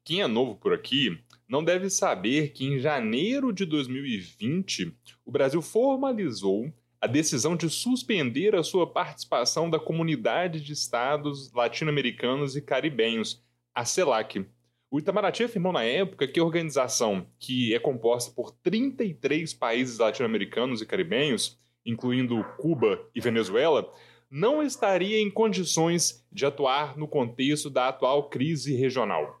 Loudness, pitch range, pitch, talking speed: -27 LUFS, 125-185 Hz, 150 Hz, 135 wpm